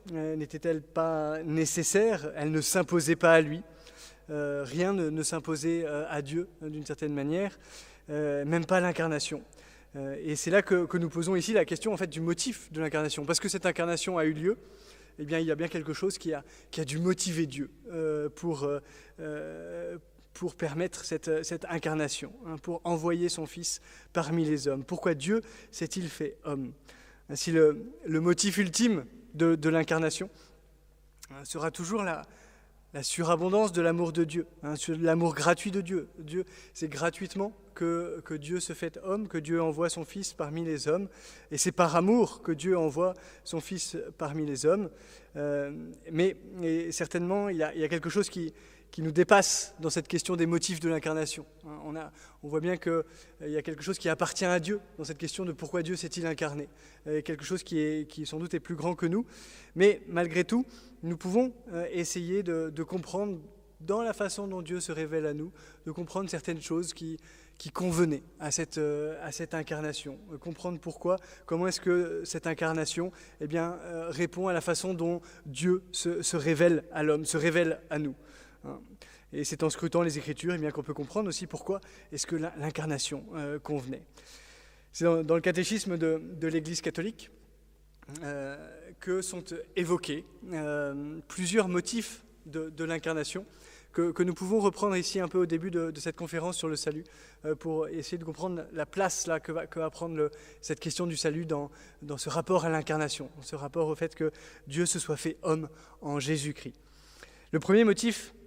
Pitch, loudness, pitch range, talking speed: 165 Hz, -31 LUFS, 155-180 Hz, 195 wpm